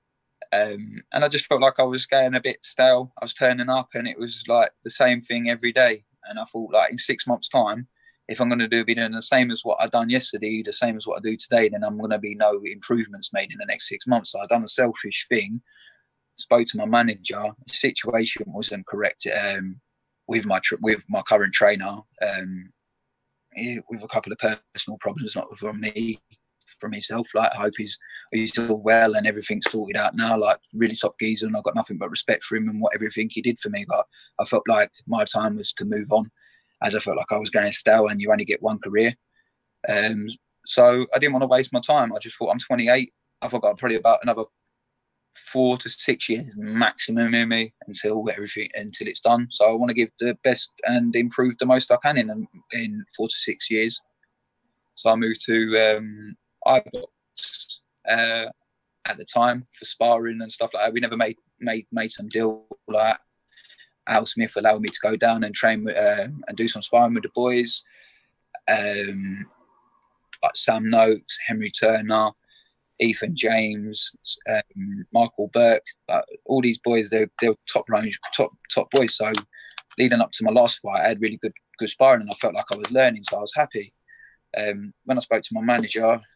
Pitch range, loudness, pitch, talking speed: 110-125 Hz, -22 LUFS, 115 Hz, 210 wpm